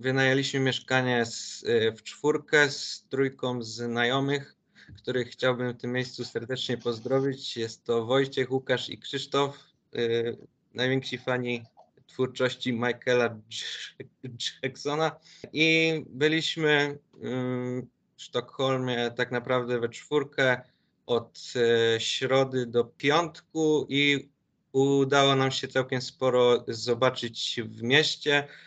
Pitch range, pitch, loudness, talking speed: 120-140 Hz, 130 Hz, -27 LUFS, 105 wpm